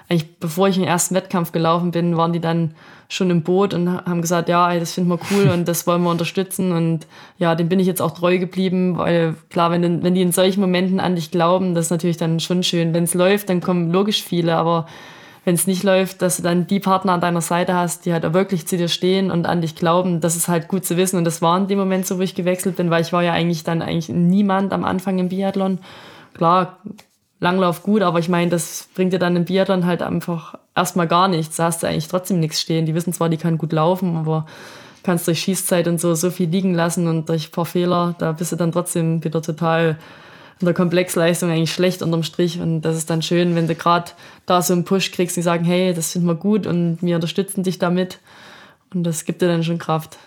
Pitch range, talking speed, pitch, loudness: 170-185 Hz, 245 wpm, 175 Hz, -19 LUFS